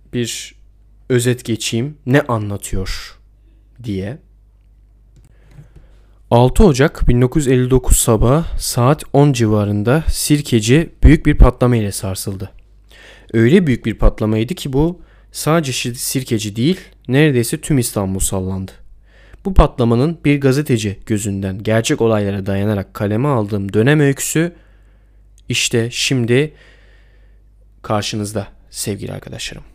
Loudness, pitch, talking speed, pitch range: -16 LUFS, 115 Hz, 100 wpm, 105-135 Hz